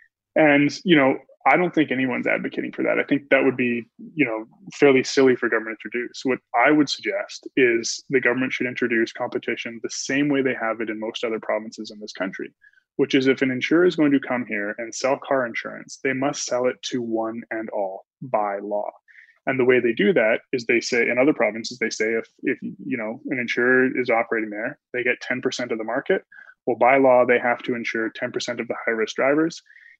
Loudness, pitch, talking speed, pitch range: -22 LUFS, 125 Hz, 225 wpm, 115-135 Hz